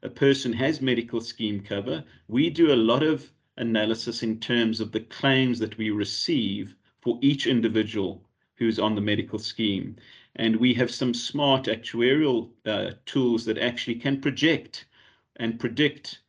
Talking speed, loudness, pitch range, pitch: 160 wpm, -25 LUFS, 110-130 Hz, 115 Hz